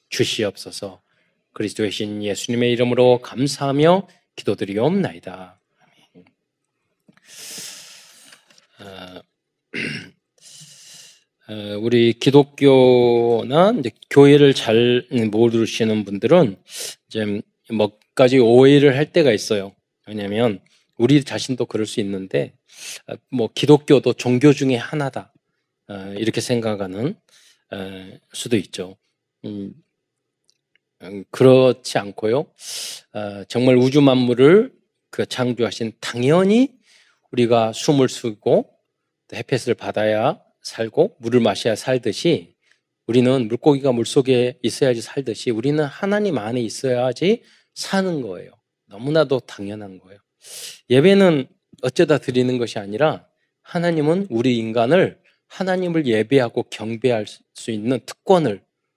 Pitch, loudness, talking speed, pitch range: 125 Hz, -18 LUFS, 230 characters per minute, 110-145 Hz